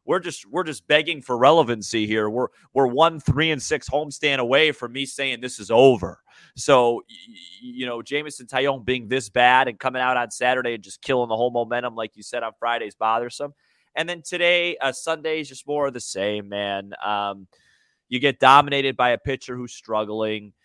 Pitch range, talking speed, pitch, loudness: 120-145 Hz, 200 wpm, 130 Hz, -22 LUFS